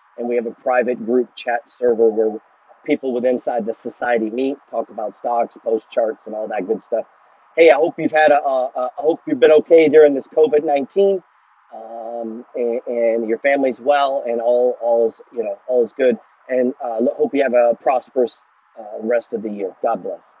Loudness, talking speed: -18 LUFS, 205 wpm